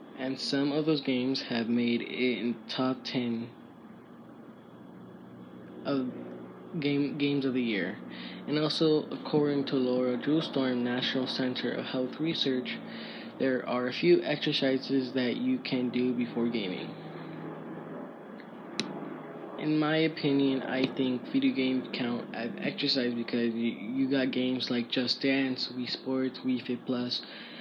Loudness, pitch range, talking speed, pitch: -30 LUFS, 120-140 Hz, 135 wpm, 130 Hz